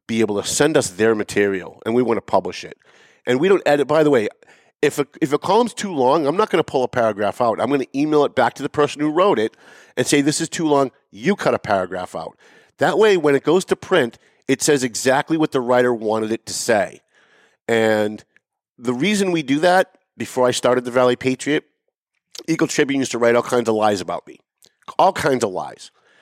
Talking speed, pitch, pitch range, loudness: 235 wpm, 130 Hz, 115-150 Hz, -19 LUFS